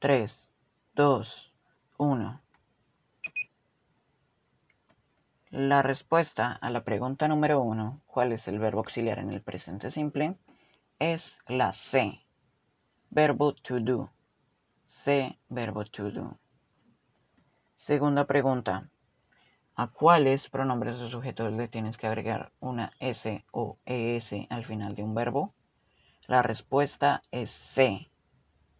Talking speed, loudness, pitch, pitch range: 110 wpm, -29 LUFS, 125 Hz, 110-140 Hz